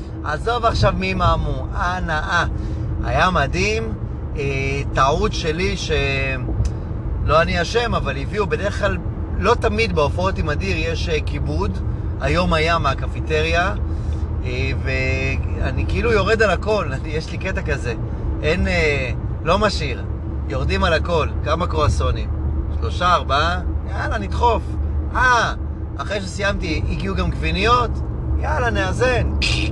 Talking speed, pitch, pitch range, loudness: 125 wpm, 80 Hz, 75-90 Hz, -20 LUFS